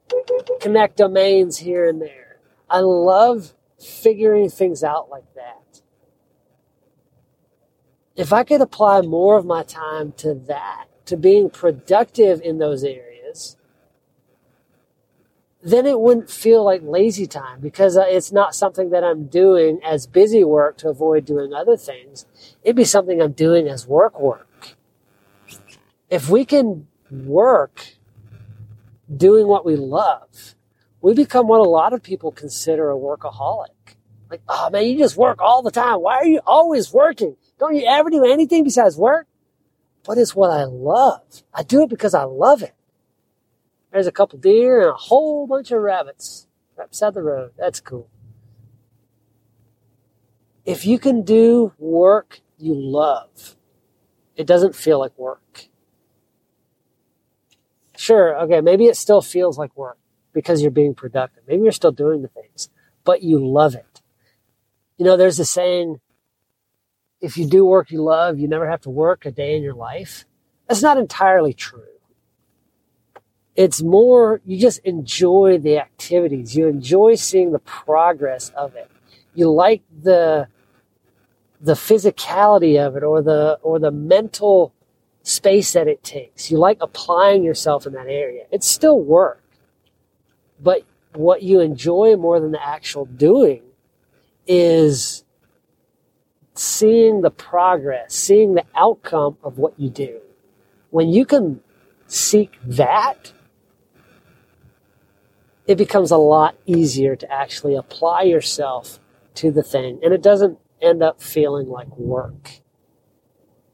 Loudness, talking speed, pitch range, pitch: -16 LUFS, 140 wpm, 140-210 Hz, 165 Hz